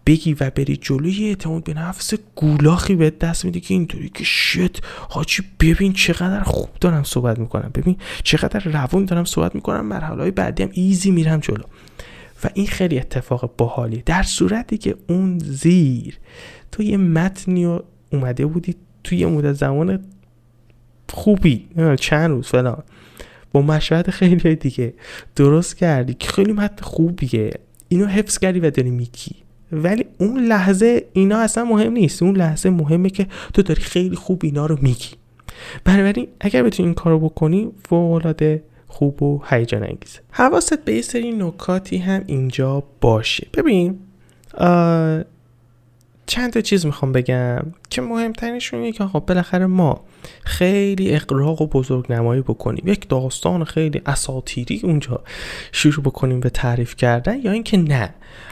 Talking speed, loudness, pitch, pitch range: 150 wpm, -18 LUFS, 165 Hz, 135-190 Hz